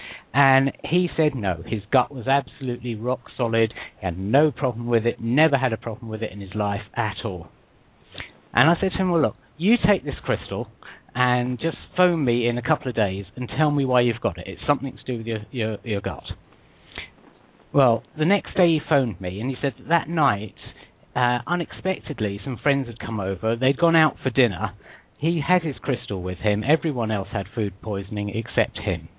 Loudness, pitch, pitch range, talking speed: -23 LUFS, 125 Hz, 110-145 Hz, 210 wpm